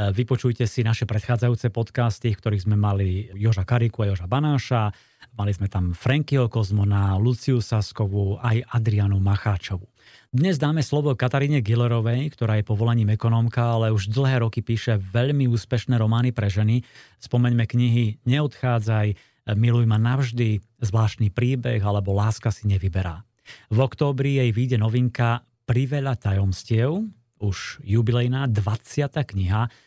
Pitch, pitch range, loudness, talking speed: 115 Hz, 105-125 Hz, -23 LUFS, 135 wpm